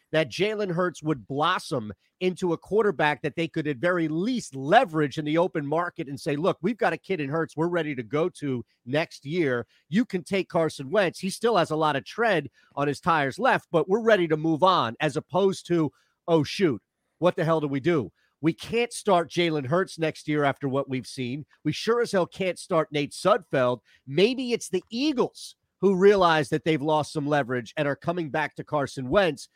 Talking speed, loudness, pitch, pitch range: 215 wpm, -26 LUFS, 160 Hz, 145-180 Hz